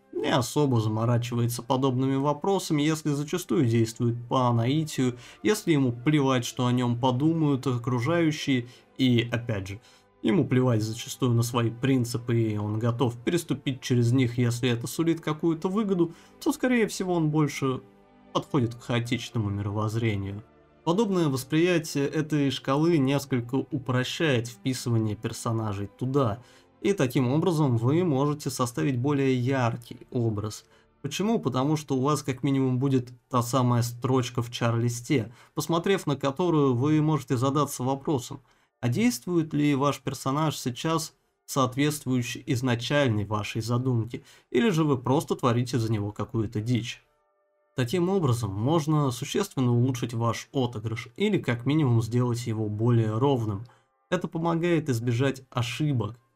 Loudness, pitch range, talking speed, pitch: -26 LUFS, 120-150 Hz, 130 wpm, 130 Hz